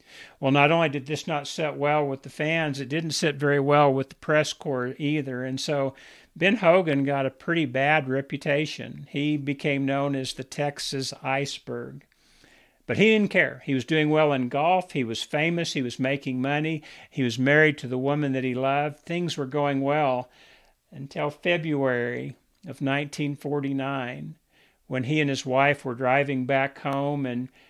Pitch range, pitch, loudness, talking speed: 135-150 Hz, 145 Hz, -25 LUFS, 175 wpm